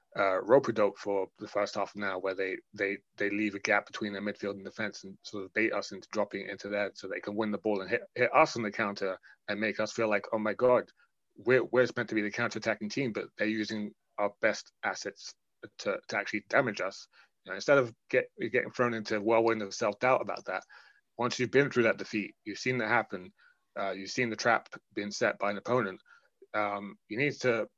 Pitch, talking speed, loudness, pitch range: 105 Hz, 235 wpm, -31 LUFS, 100-120 Hz